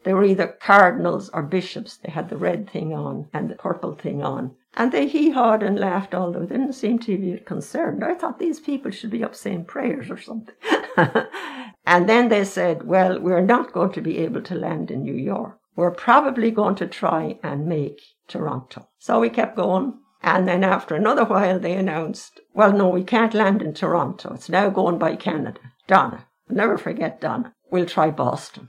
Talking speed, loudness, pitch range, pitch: 195 wpm, -21 LUFS, 180-230 Hz, 200 Hz